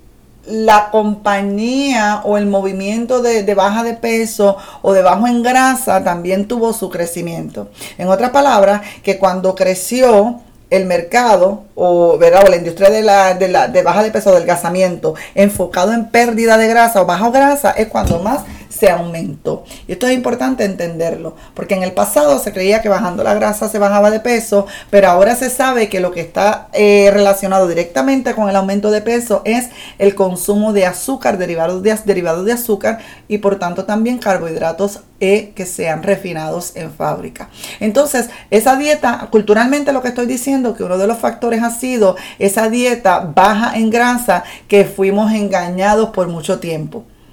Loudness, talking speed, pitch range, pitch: -13 LUFS, 170 wpm, 190-235 Hz, 205 Hz